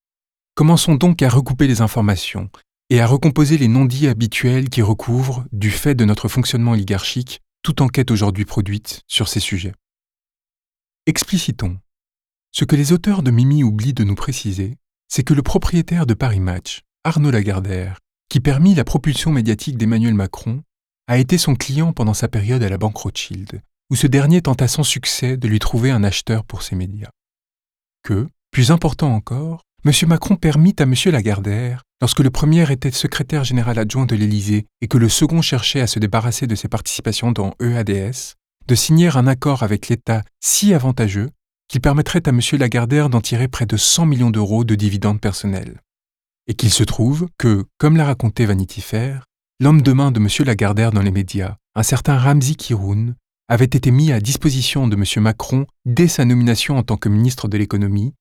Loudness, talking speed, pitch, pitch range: -17 LUFS, 180 wpm, 120 Hz, 110-140 Hz